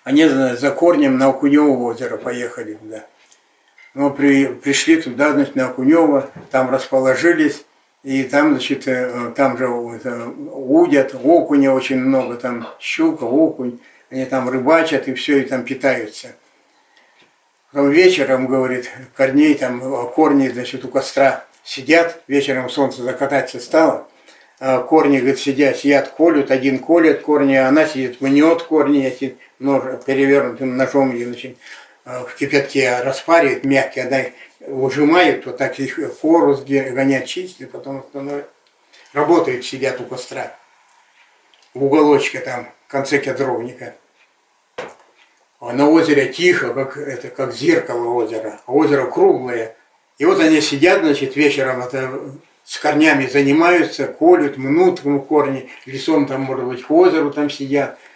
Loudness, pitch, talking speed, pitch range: -16 LUFS, 140 Hz, 135 wpm, 130-150 Hz